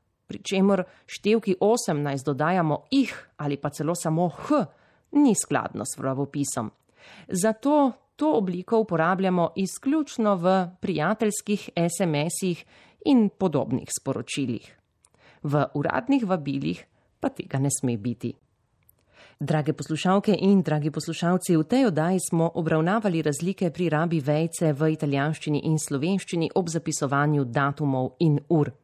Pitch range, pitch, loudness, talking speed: 145-195 Hz, 165 Hz, -25 LUFS, 115 wpm